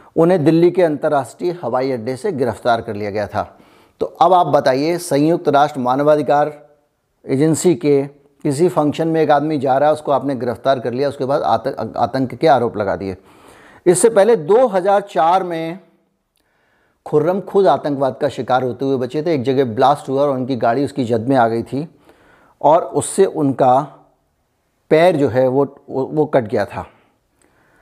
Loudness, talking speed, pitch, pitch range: -16 LUFS, 175 wpm, 145 Hz, 130-160 Hz